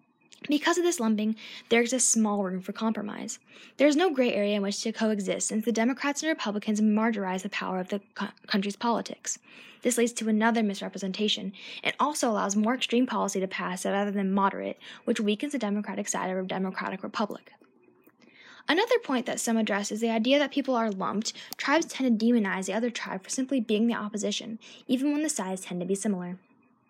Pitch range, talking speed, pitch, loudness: 205-250 Hz, 200 wpm, 225 Hz, -28 LUFS